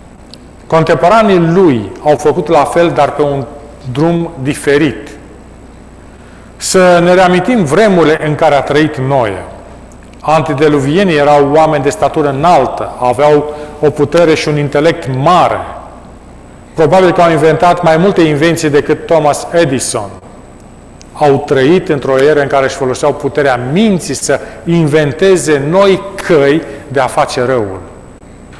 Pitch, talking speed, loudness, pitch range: 150 Hz, 130 wpm, -10 LUFS, 140-170 Hz